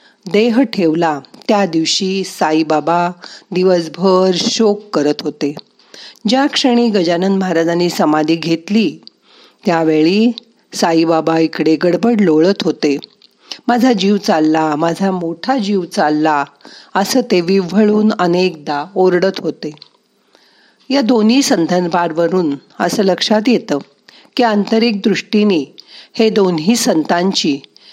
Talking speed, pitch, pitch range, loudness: 100 wpm, 185 Hz, 165-215 Hz, -14 LUFS